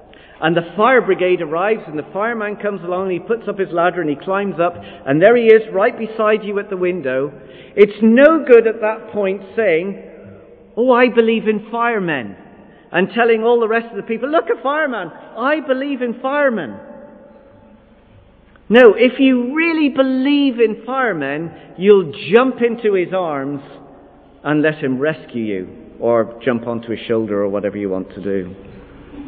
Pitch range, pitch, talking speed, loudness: 150-240 Hz, 205 Hz, 175 wpm, -16 LUFS